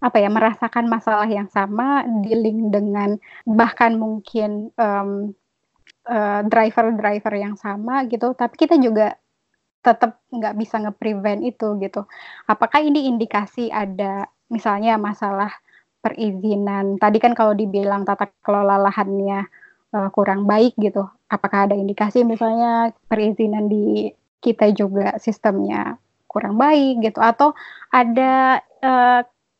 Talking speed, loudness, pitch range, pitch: 120 wpm, -19 LUFS, 205-235 Hz, 215 Hz